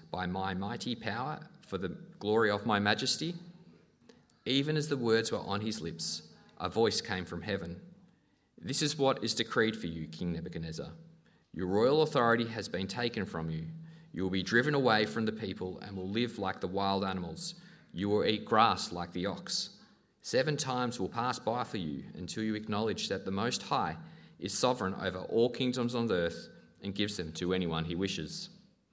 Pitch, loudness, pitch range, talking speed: 105 Hz, -33 LUFS, 95-125 Hz, 190 wpm